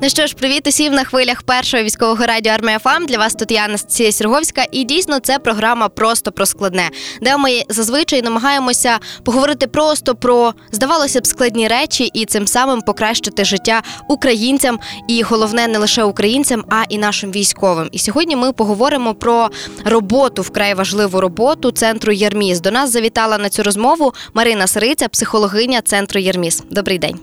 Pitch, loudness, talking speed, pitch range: 230 Hz, -14 LUFS, 165 wpm, 210-260 Hz